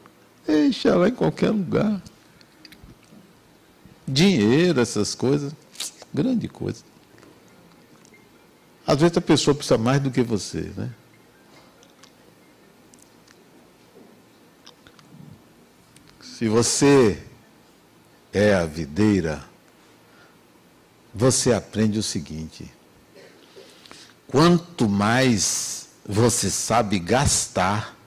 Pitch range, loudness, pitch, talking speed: 105-155 Hz, -21 LUFS, 120 Hz, 75 wpm